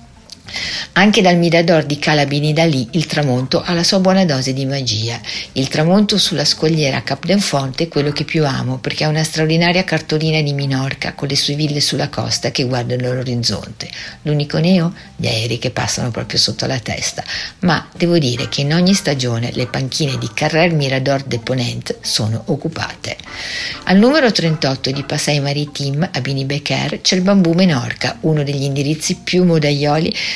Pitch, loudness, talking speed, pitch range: 145 Hz, -16 LUFS, 170 wpm, 130-165 Hz